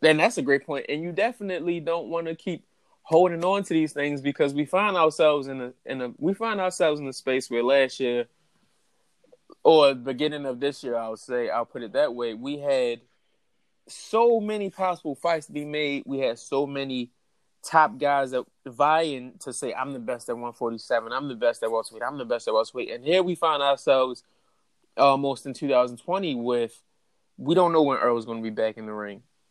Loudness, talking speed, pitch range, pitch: -25 LUFS, 210 wpm, 125-170 Hz, 145 Hz